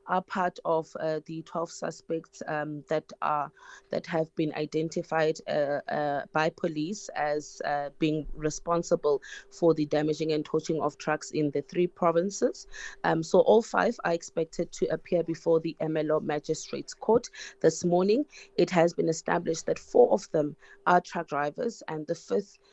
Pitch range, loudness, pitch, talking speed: 155-175 Hz, -29 LUFS, 160 Hz, 165 wpm